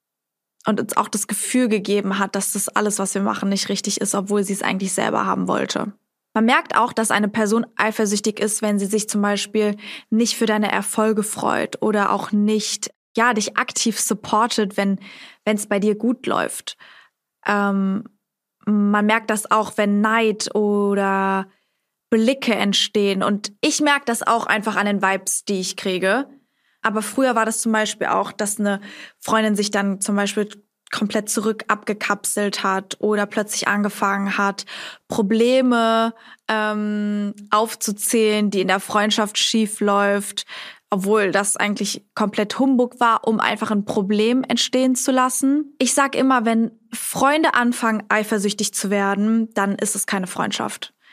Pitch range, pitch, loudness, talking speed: 205-225 Hz, 210 Hz, -20 LUFS, 155 wpm